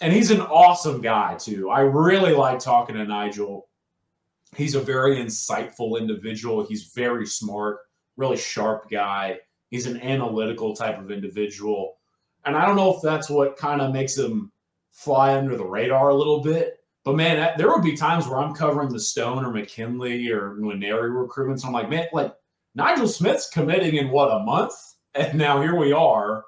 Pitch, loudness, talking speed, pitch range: 130 Hz, -22 LUFS, 180 wpm, 110-150 Hz